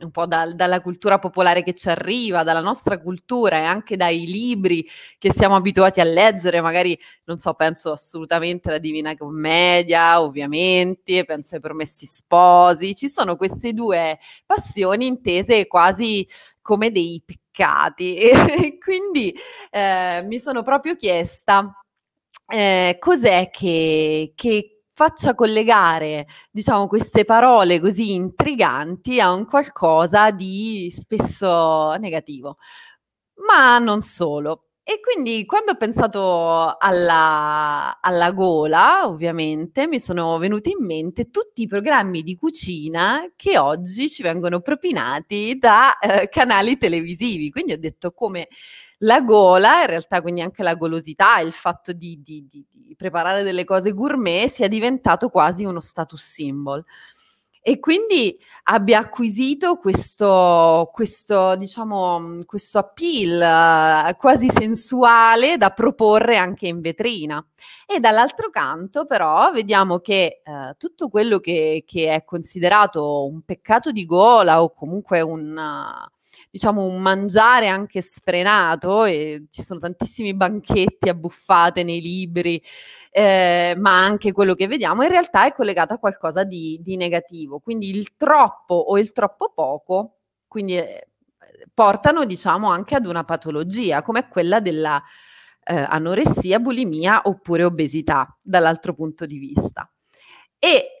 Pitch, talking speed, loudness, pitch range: 185 Hz, 130 wpm, -17 LUFS, 170-225 Hz